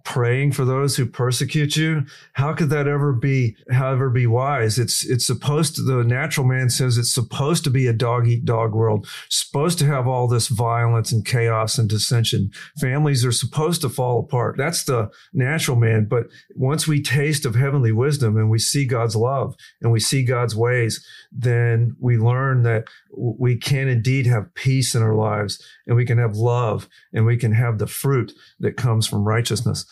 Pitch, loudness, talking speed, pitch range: 125 Hz, -20 LUFS, 185 wpm, 115-135 Hz